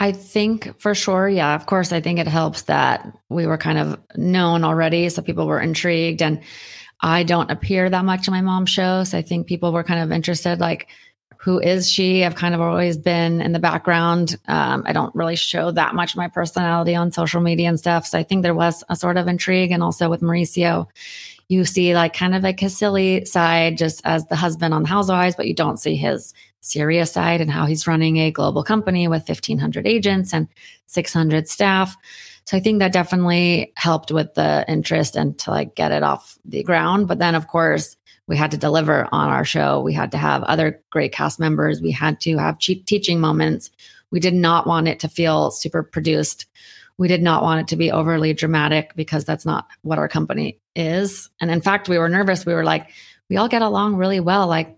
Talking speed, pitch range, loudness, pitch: 220 wpm, 160-185 Hz, -19 LUFS, 170 Hz